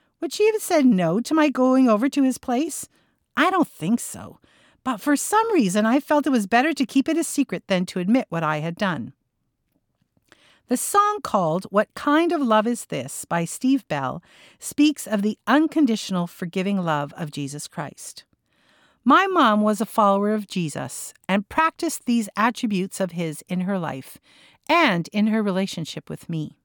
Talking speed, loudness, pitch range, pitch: 180 wpm, -22 LUFS, 185-280 Hz, 220 Hz